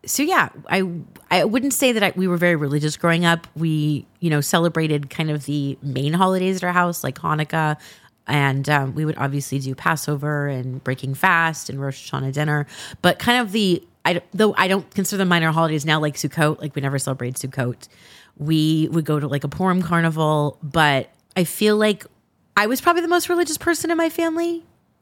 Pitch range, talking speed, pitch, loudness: 145-190 Hz, 200 wpm, 160 Hz, -20 LUFS